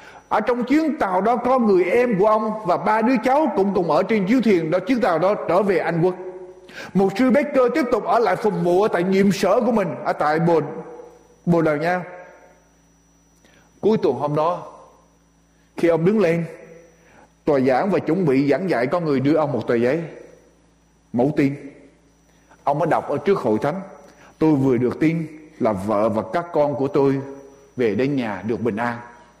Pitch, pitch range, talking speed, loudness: 170 Hz, 145-200 Hz, 200 wpm, -20 LUFS